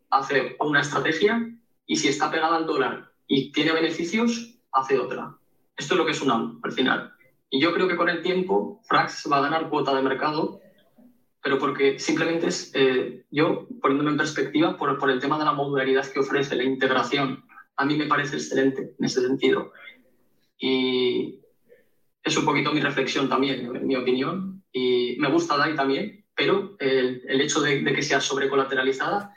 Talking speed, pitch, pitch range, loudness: 180 wpm, 150 Hz, 135-190 Hz, -24 LUFS